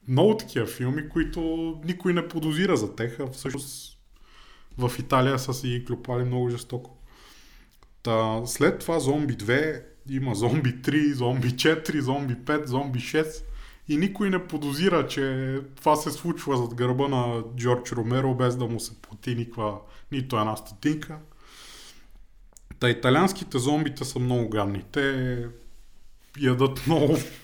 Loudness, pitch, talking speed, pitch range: -26 LUFS, 130 Hz, 135 wpm, 120-150 Hz